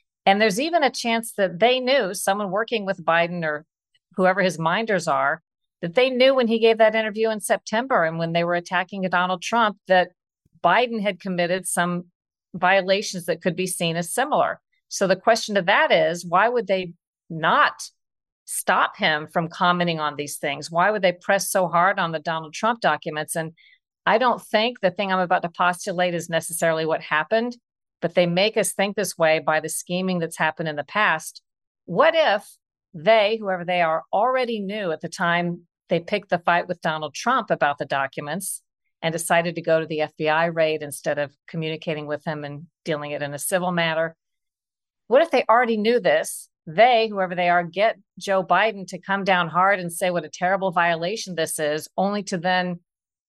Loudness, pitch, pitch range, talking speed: -22 LUFS, 180 Hz, 165-205 Hz, 195 wpm